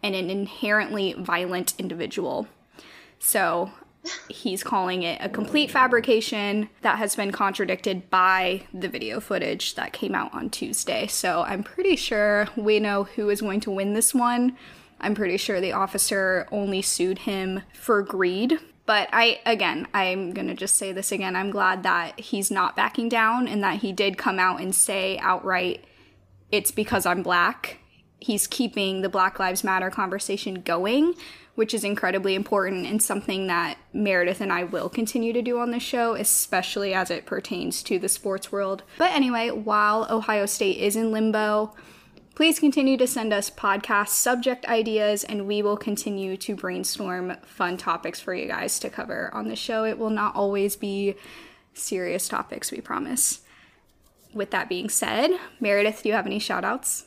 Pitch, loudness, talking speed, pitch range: 205 Hz, -24 LUFS, 170 wpm, 190-225 Hz